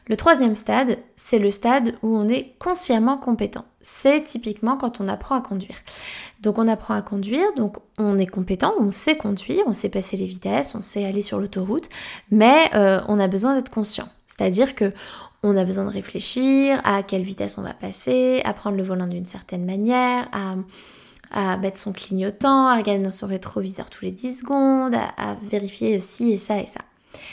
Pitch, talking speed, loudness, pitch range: 215 Hz, 195 wpm, -21 LUFS, 195-250 Hz